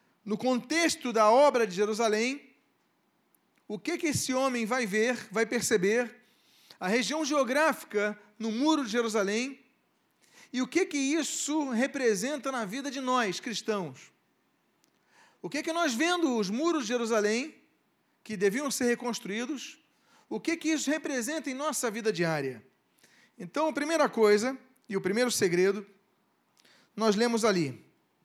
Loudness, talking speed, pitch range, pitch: -29 LUFS, 140 wpm, 215-290 Hz, 245 Hz